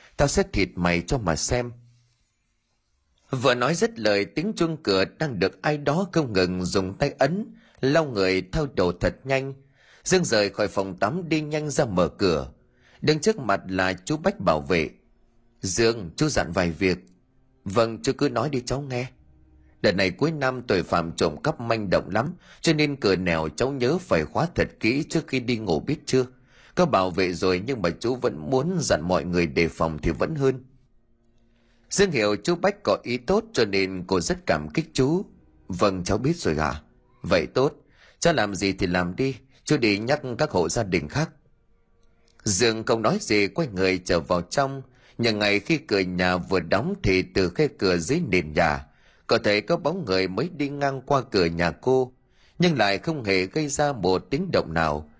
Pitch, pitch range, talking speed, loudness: 120 Hz, 95-145 Hz, 200 wpm, -24 LUFS